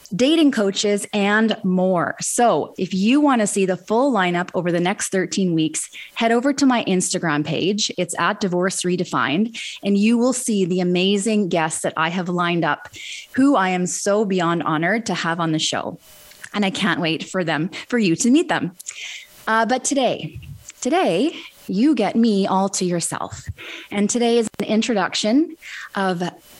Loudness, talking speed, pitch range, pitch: -20 LUFS, 175 wpm, 175-230 Hz, 195 Hz